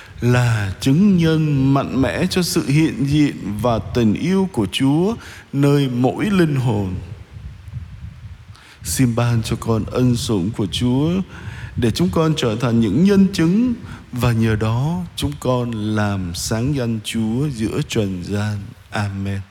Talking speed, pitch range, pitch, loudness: 145 wpm, 105-145 Hz, 120 Hz, -18 LUFS